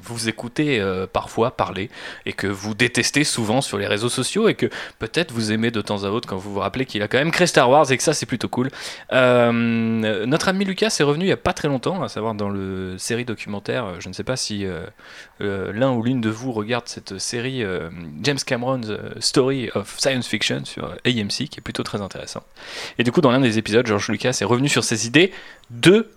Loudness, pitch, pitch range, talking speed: -21 LUFS, 120 Hz, 105-130 Hz, 235 wpm